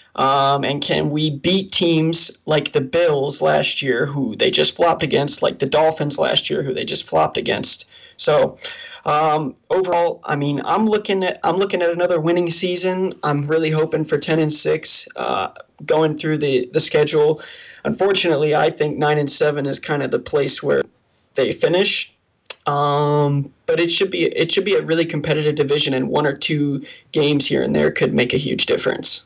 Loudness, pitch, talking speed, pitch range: -18 LUFS, 155 Hz, 190 wpm, 145-190 Hz